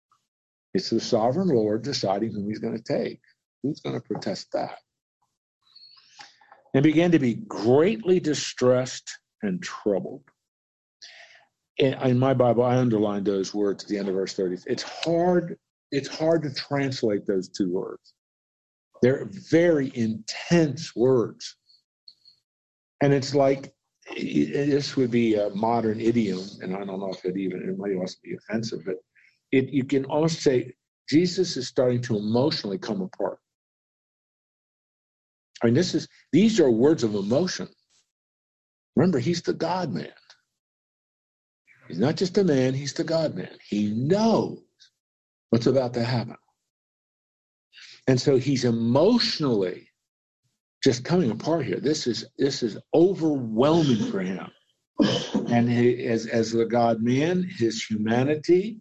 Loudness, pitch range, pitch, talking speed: -24 LUFS, 110-150 Hz, 125 Hz, 140 wpm